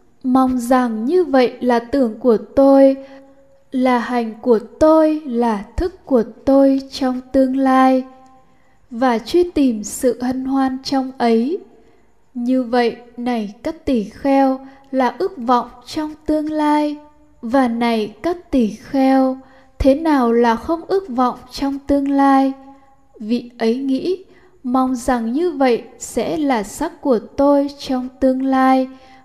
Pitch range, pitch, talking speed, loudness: 245-280 Hz, 265 Hz, 140 wpm, -17 LUFS